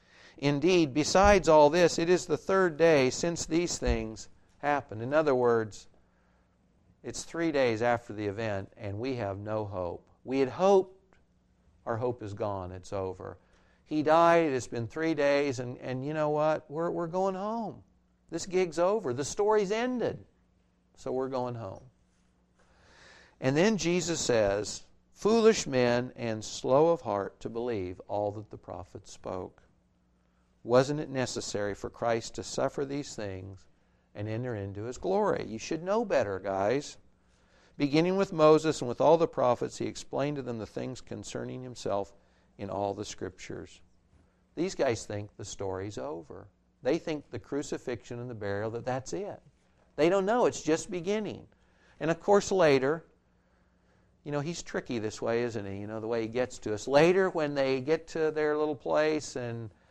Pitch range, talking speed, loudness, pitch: 105-160 Hz, 170 wpm, -29 LUFS, 125 Hz